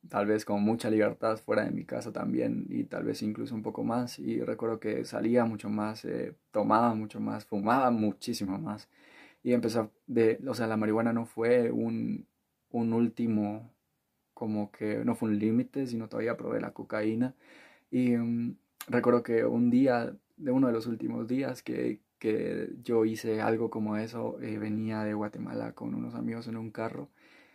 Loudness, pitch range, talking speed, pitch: -31 LUFS, 105-120 Hz, 180 wpm, 115 Hz